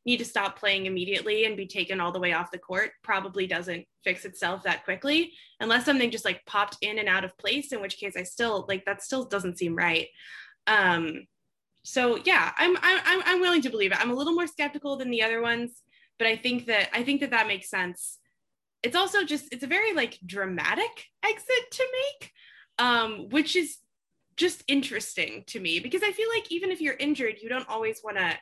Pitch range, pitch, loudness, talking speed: 195-310 Hz, 235 Hz, -27 LUFS, 215 wpm